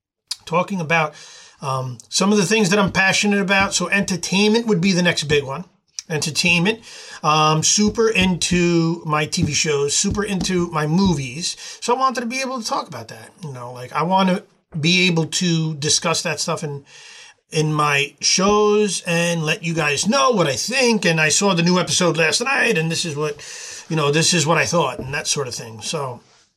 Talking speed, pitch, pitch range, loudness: 200 wpm, 170 Hz, 155-200 Hz, -18 LUFS